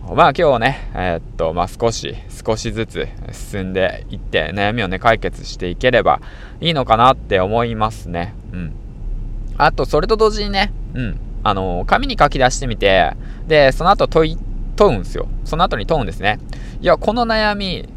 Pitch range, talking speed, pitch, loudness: 105-135 Hz, 295 characters per minute, 115 Hz, -17 LUFS